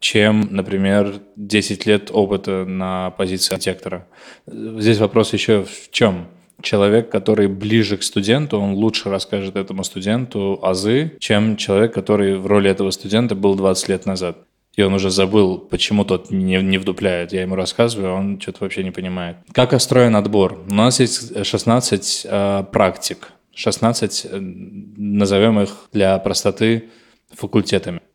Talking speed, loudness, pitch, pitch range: 145 wpm, -18 LUFS, 100 Hz, 95-110 Hz